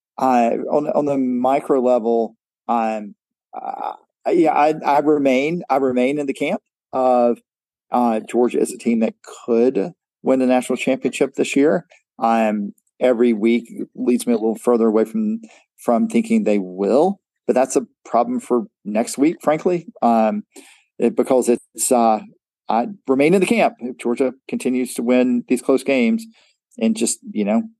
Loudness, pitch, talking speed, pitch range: -19 LUFS, 125 Hz, 165 wpm, 115-145 Hz